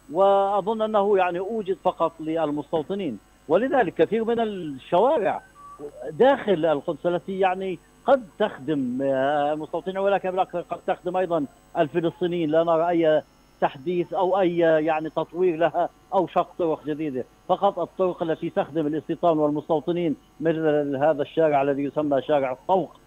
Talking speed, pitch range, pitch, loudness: 125 wpm, 155-185 Hz, 170 Hz, -24 LUFS